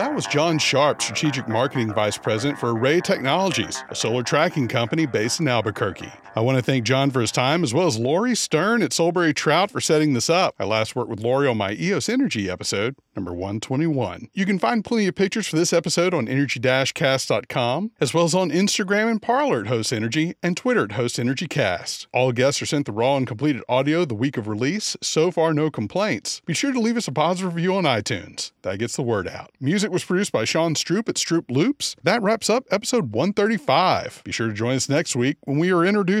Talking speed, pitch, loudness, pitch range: 220 wpm, 150 Hz, -21 LUFS, 125-185 Hz